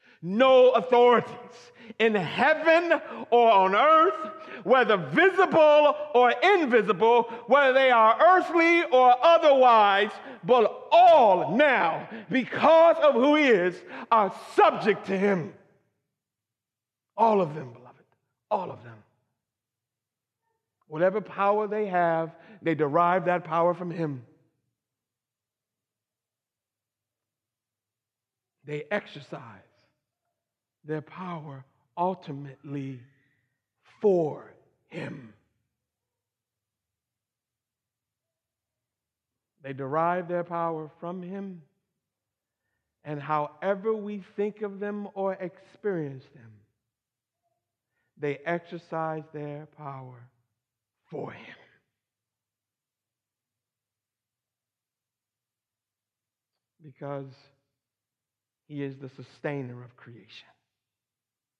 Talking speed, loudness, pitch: 80 wpm, -23 LUFS, 155 Hz